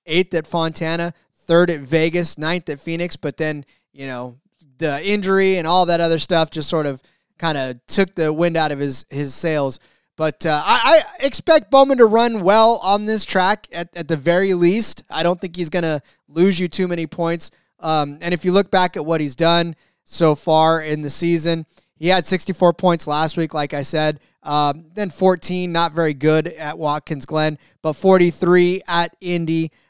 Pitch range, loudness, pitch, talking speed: 155-180 Hz, -18 LUFS, 170 Hz, 200 wpm